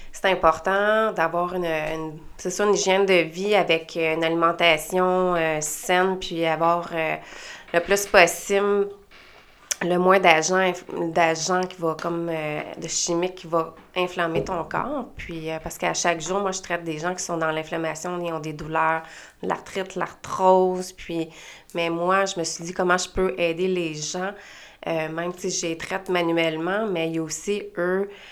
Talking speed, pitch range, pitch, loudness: 180 wpm, 165-185 Hz, 175 Hz, -23 LUFS